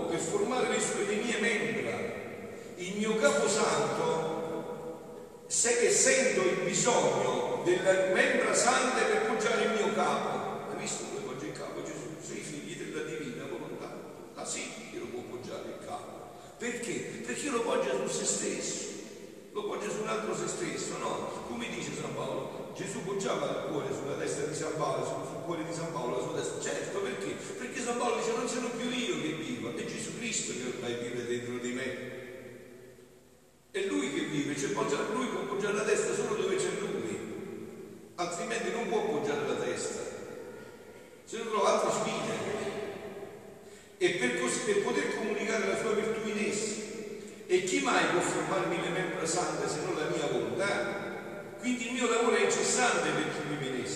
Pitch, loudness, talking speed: 220 Hz, -32 LUFS, 175 wpm